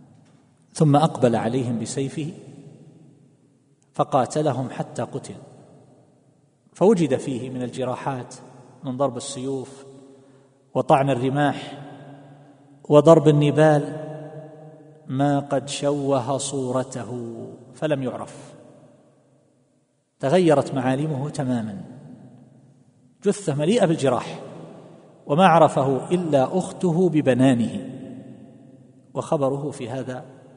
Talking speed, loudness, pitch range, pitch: 75 wpm, -22 LUFS, 130-150 Hz, 140 Hz